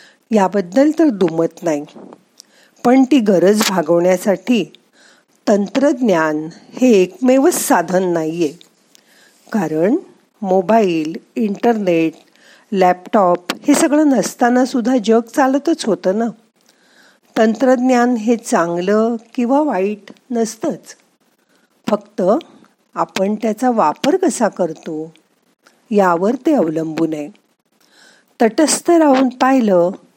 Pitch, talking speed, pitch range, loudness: 225 Hz, 90 wpm, 185-260 Hz, -15 LUFS